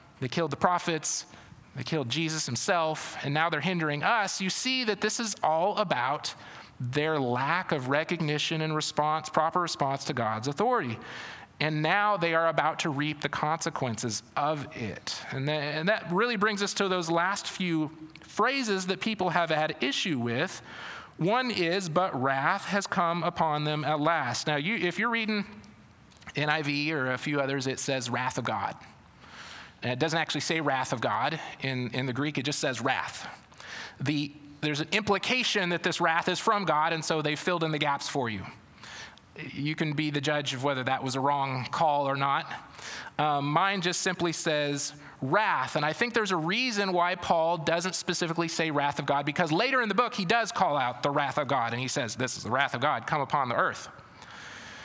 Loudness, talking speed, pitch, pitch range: -28 LUFS, 195 wpm, 155 Hz, 145-180 Hz